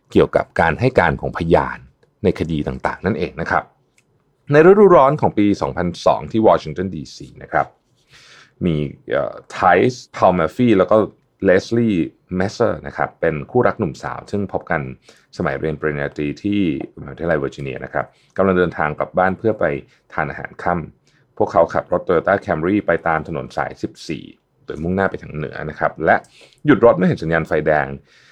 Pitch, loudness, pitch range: 90 Hz, -18 LUFS, 75-105 Hz